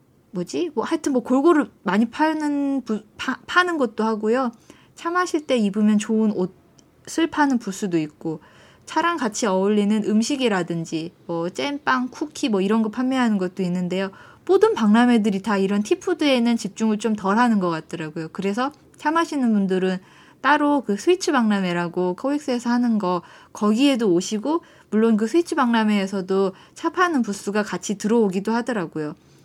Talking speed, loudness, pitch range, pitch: 340 characters per minute, -22 LUFS, 195-280 Hz, 220 Hz